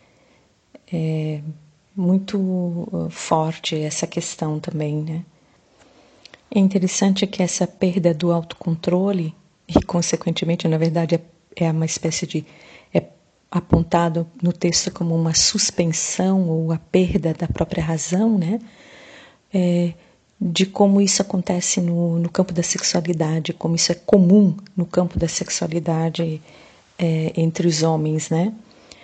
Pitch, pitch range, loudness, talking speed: 170 Hz, 165-185 Hz, -20 LUFS, 120 wpm